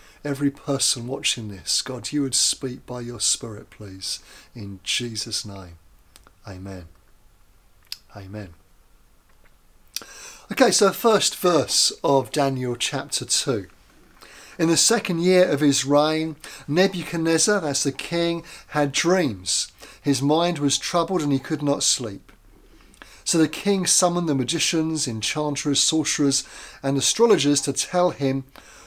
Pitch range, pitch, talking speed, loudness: 120-165 Hz, 140 Hz, 125 wpm, -21 LUFS